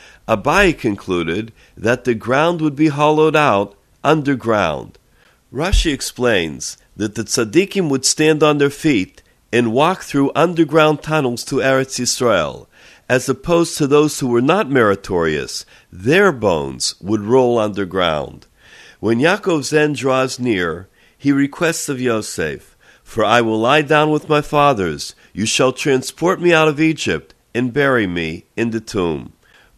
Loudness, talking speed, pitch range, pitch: -16 LUFS, 145 wpm, 115-155 Hz, 135 Hz